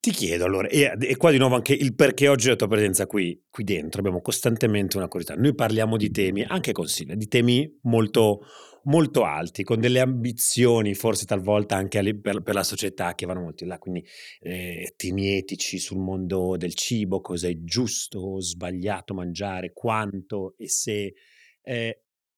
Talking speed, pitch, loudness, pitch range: 180 wpm, 100 Hz, -24 LUFS, 95-120 Hz